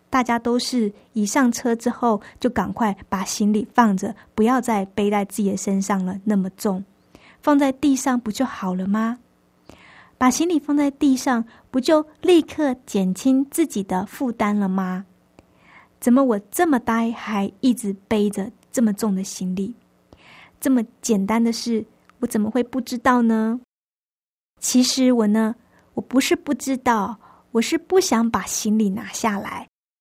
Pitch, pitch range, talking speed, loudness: 230 Hz, 205-255 Hz, 220 characters per minute, -21 LUFS